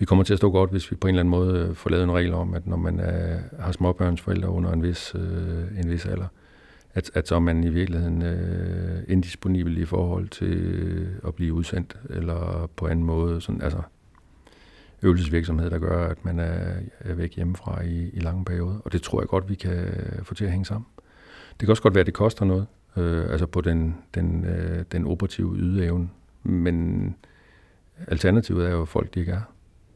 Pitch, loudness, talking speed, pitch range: 90 Hz, -25 LUFS, 205 wpm, 85-95 Hz